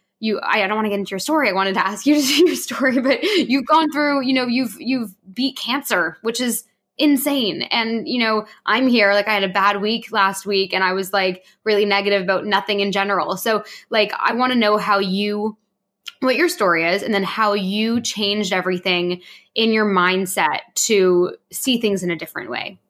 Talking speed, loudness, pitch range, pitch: 215 wpm, -19 LUFS, 195-250 Hz, 210 Hz